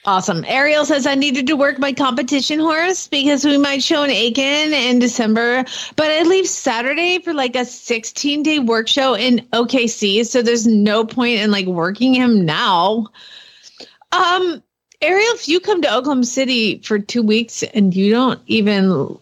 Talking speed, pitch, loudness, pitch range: 170 wpm, 260 Hz, -16 LUFS, 230-300 Hz